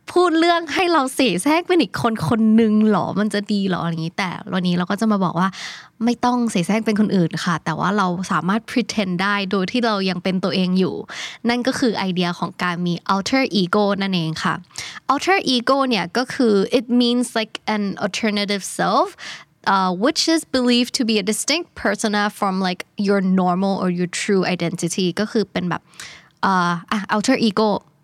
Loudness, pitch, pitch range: -19 LUFS, 205 Hz, 185-240 Hz